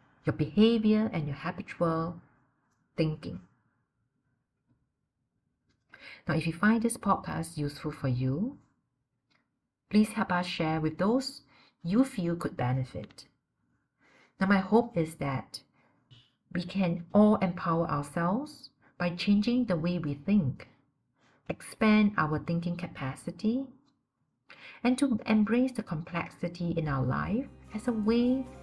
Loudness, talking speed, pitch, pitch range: -30 LUFS, 115 wpm, 175 Hz, 150-215 Hz